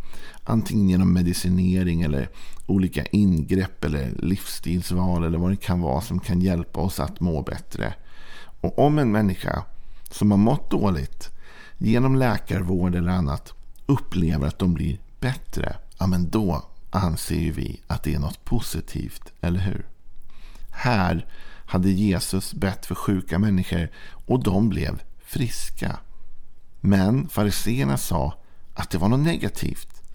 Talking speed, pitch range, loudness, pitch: 135 wpm, 85-100 Hz, -24 LUFS, 90 Hz